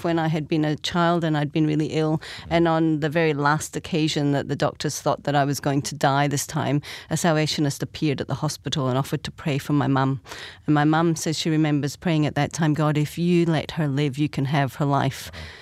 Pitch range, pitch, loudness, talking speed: 140-160 Hz, 150 Hz, -23 LUFS, 240 wpm